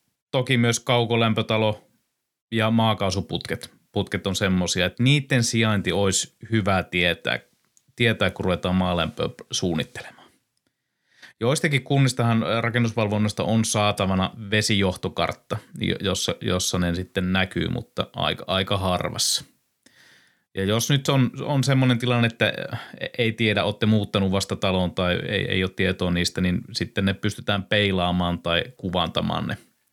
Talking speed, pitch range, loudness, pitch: 125 wpm, 95-115 Hz, -23 LUFS, 105 Hz